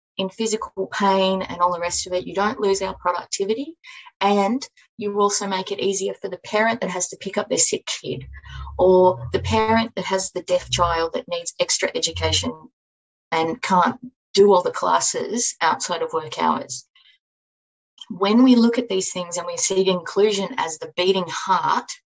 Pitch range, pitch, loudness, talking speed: 180-235 Hz, 195 Hz, -21 LUFS, 185 wpm